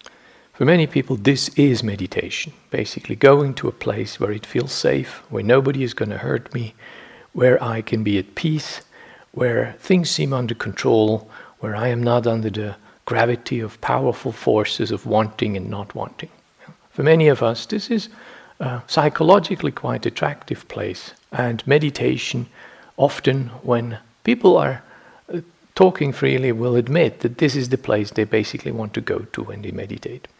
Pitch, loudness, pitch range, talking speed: 125 Hz, -20 LUFS, 115-150 Hz, 165 wpm